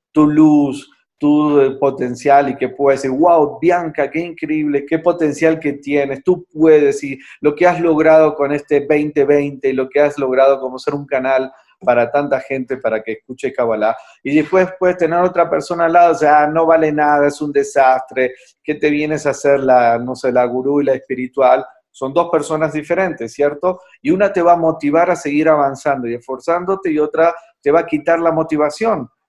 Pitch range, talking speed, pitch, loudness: 135-165 Hz, 195 wpm, 150 Hz, -15 LUFS